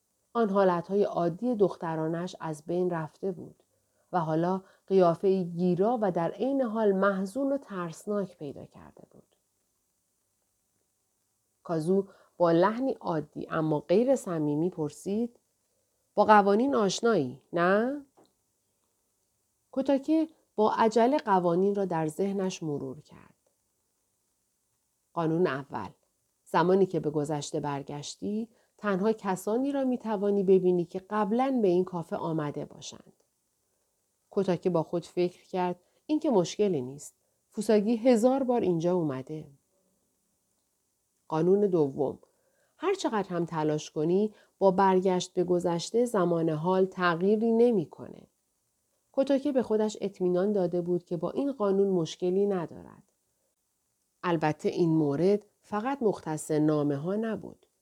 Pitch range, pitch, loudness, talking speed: 165-215 Hz, 185 Hz, -28 LUFS, 115 wpm